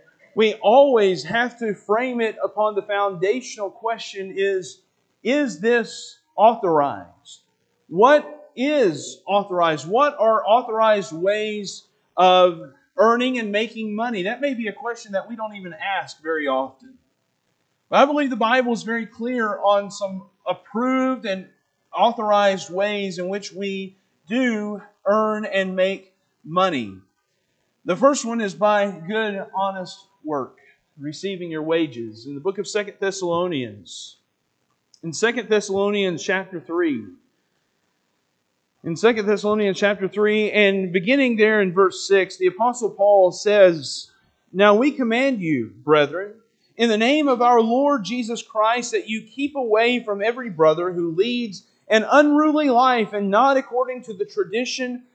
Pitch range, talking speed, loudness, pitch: 190-235 Hz, 140 wpm, -20 LUFS, 210 Hz